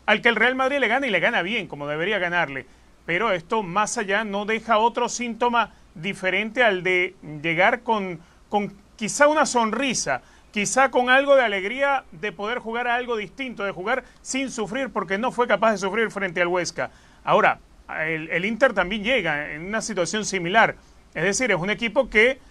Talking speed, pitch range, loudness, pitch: 190 wpm, 185-245 Hz, -22 LUFS, 215 Hz